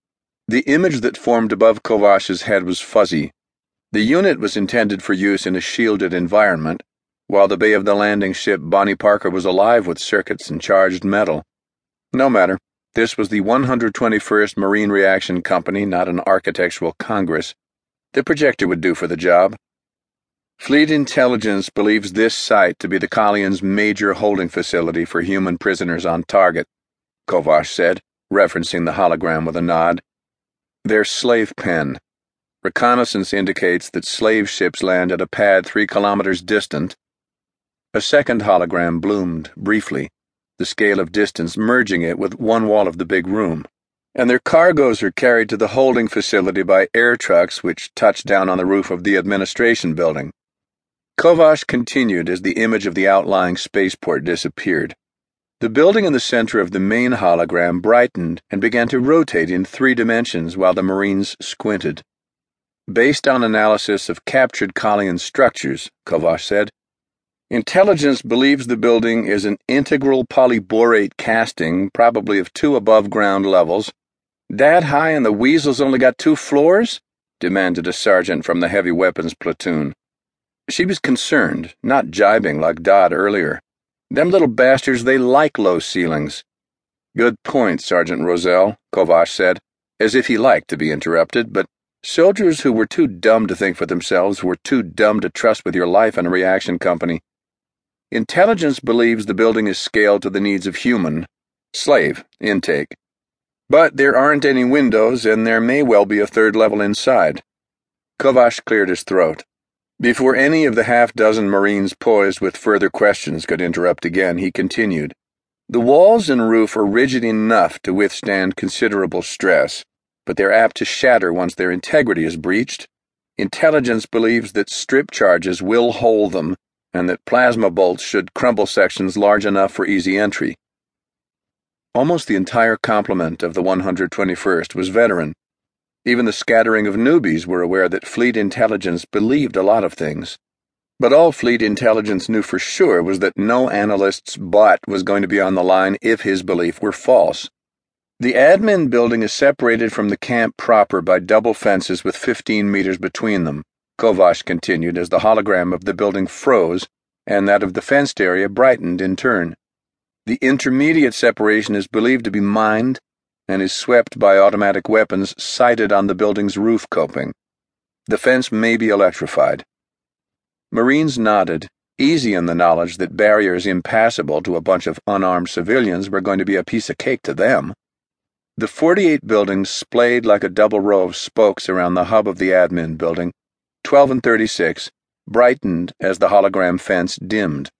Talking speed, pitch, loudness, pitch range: 160 wpm, 105 Hz, -16 LUFS, 95-115 Hz